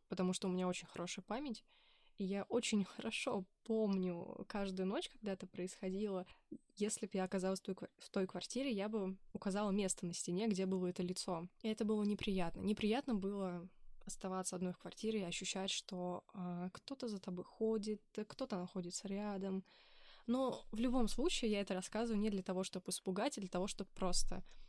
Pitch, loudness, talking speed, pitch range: 195 Hz, -42 LUFS, 175 wpm, 185-220 Hz